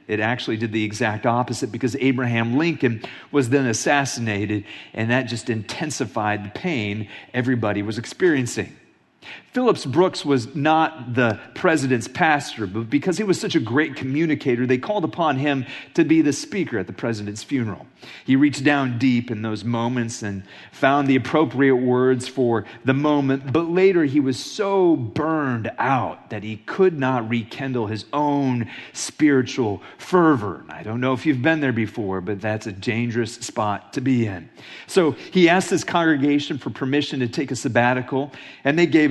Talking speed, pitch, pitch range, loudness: 170 wpm, 130 Hz, 115-145 Hz, -21 LUFS